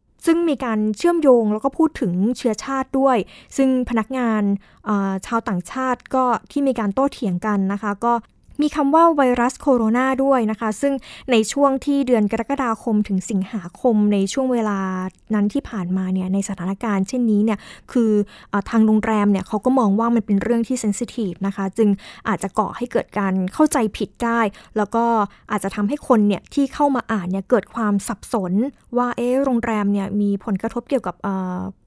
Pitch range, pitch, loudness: 205-255 Hz, 225 Hz, -20 LUFS